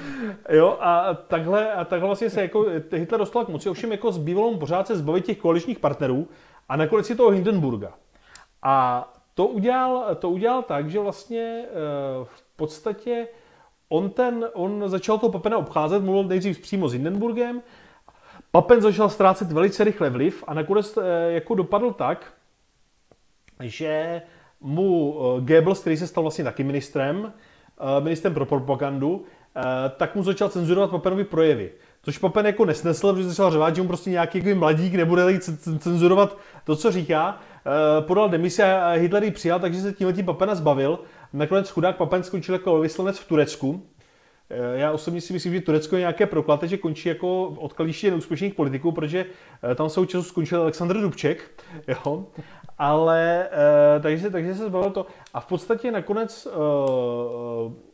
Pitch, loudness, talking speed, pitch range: 175 Hz, -23 LUFS, 150 wpm, 155-200 Hz